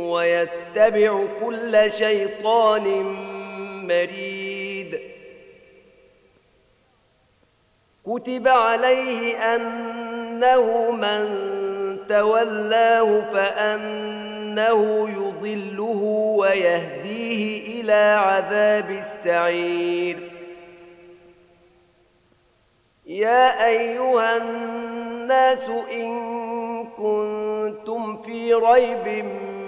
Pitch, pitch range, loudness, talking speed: 215 Hz, 195-230 Hz, -21 LUFS, 45 wpm